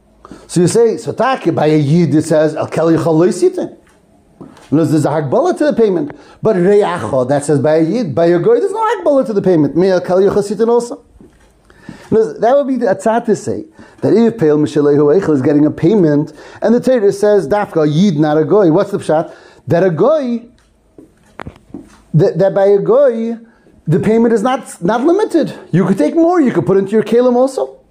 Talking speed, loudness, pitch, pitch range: 185 wpm, -13 LUFS, 195 Hz, 160-240 Hz